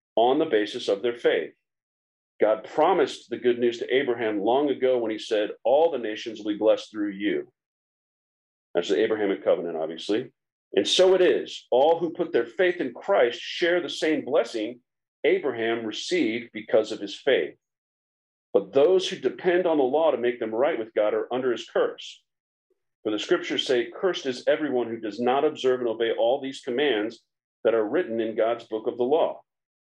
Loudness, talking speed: -25 LUFS, 190 wpm